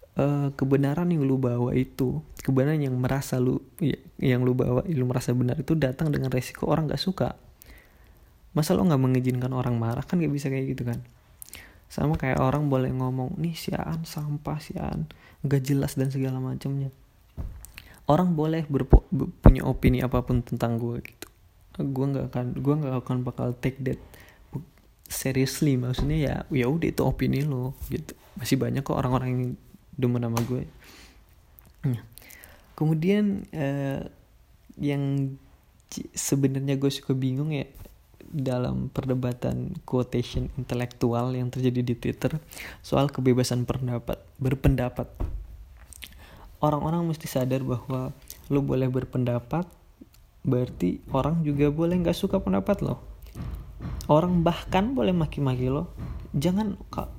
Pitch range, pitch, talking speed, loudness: 125-145 Hz, 130 Hz, 135 wpm, -27 LUFS